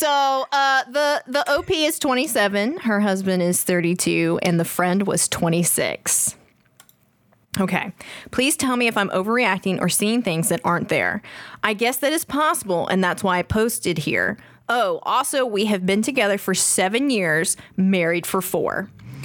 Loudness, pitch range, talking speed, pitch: -20 LUFS, 180-260 Hz, 160 wpm, 200 Hz